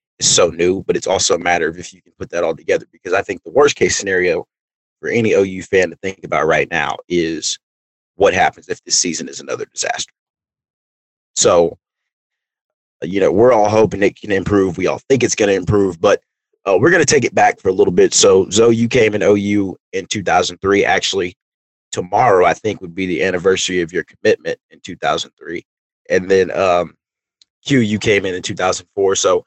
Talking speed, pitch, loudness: 205 wpm, 110 Hz, -15 LUFS